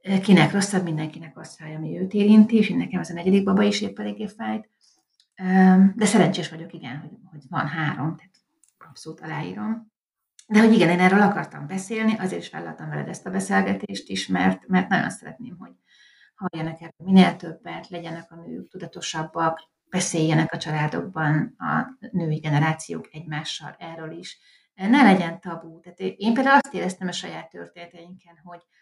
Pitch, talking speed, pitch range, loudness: 175 Hz, 160 wpm, 160-195 Hz, -22 LUFS